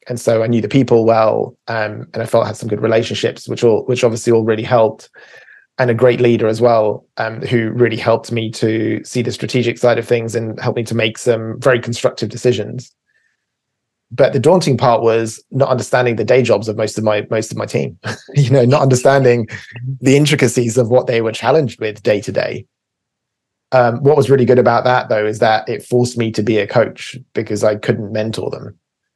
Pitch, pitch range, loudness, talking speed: 115 Hz, 110-125 Hz, -15 LUFS, 215 wpm